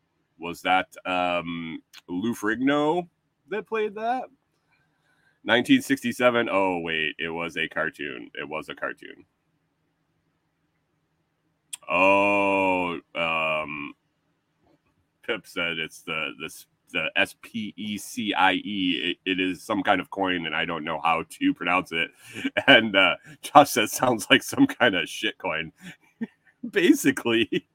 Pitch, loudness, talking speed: 120 Hz, -24 LUFS, 125 wpm